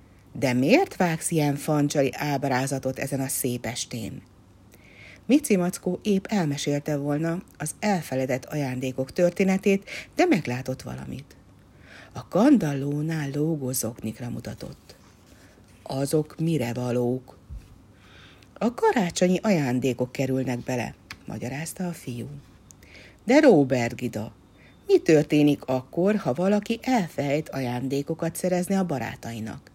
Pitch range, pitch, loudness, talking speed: 120-170 Hz, 140 Hz, -25 LUFS, 100 wpm